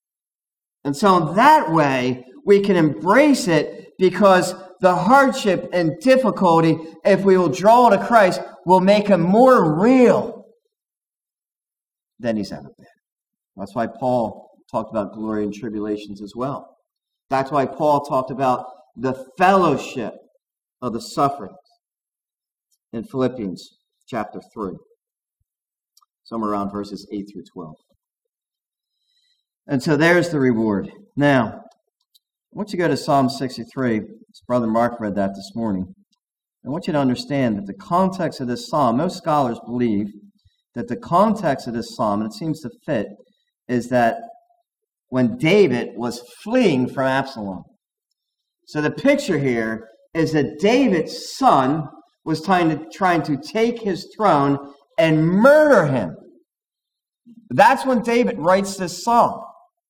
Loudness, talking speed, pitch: -19 LUFS, 135 wpm, 160 Hz